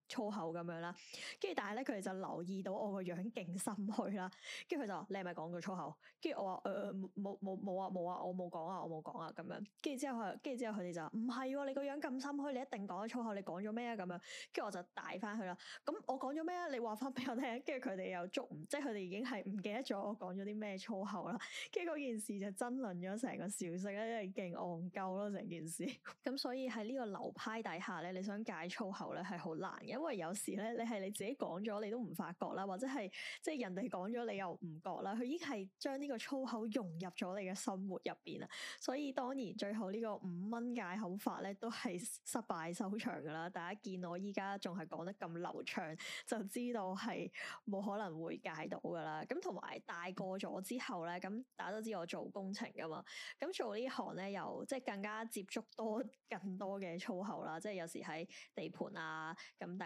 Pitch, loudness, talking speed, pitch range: 205 Hz, -45 LUFS, 330 characters per minute, 185-245 Hz